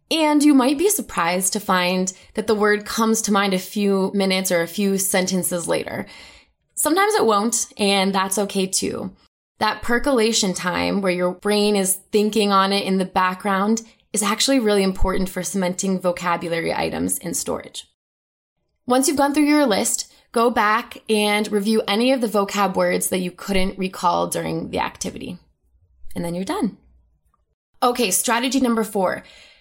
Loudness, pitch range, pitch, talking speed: -20 LUFS, 185-225 Hz, 200 Hz, 165 wpm